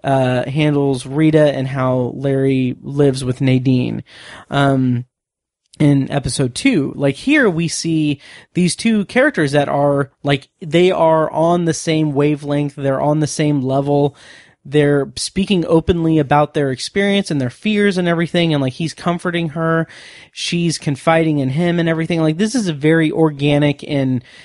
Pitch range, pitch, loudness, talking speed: 140-165 Hz, 150 Hz, -16 LUFS, 150 wpm